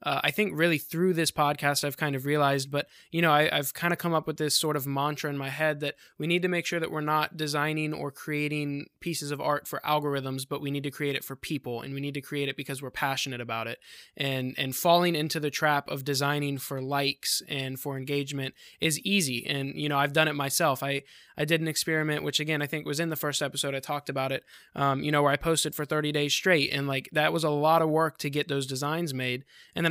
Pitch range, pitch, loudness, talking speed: 140-155 Hz, 145 Hz, -28 LUFS, 260 wpm